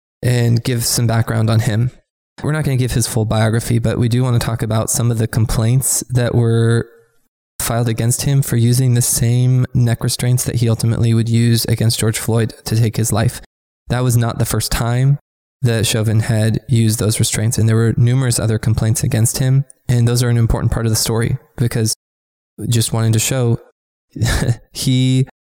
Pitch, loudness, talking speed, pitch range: 115 Hz, -16 LUFS, 195 wpm, 115-125 Hz